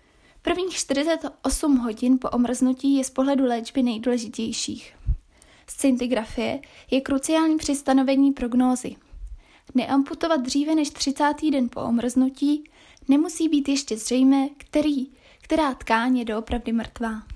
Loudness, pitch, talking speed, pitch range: -23 LUFS, 270 Hz, 115 wpm, 245-290 Hz